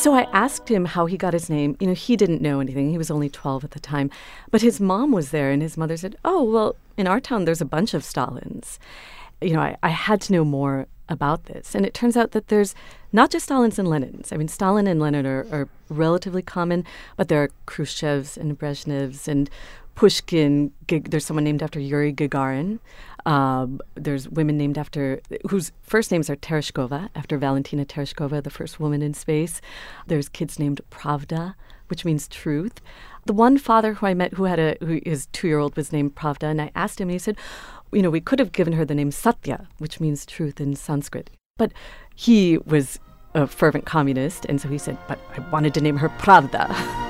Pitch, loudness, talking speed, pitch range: 155 Hz, -22 LUFS, 210 wpm, 145-190 Hz